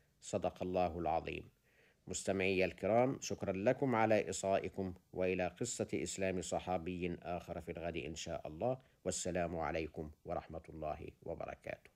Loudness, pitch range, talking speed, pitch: -39 LUFS, 85-100 Hz, 120 wpm, 90 Hz